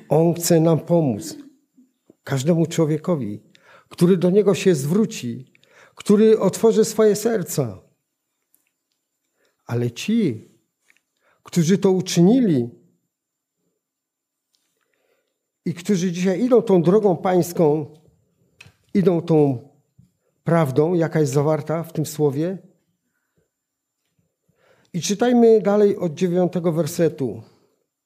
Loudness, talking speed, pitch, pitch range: -19 LUFS, 90 wpm, 175 Hz, 155-205 Hz